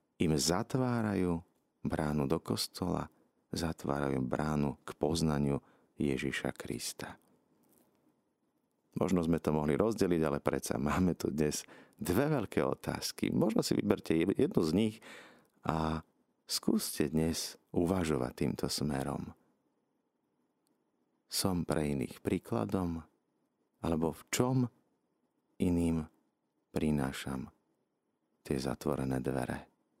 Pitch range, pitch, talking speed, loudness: 70-85 Hz, 80 Hz, 95 wpm, -34 LUFS